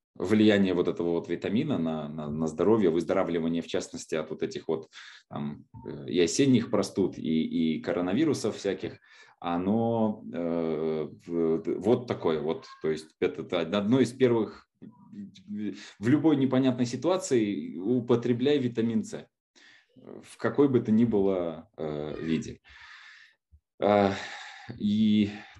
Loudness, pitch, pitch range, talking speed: -28 LUFS, 105 Hz, 80-125 Hz, 125 wpm